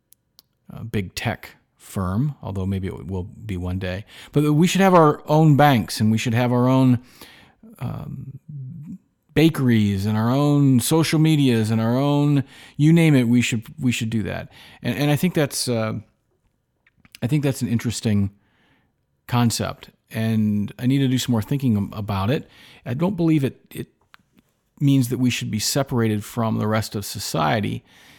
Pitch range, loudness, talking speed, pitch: 110-145 Hz, -21 LUFS, 170 wpm, 125 Hz